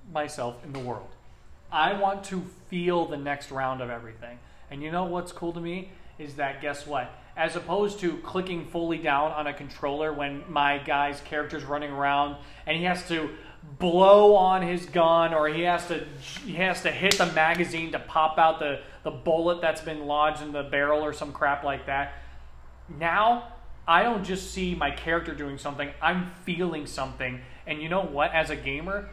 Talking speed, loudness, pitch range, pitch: 190 wpm, -26 LUFS, 145-175 Hz, 155 Hz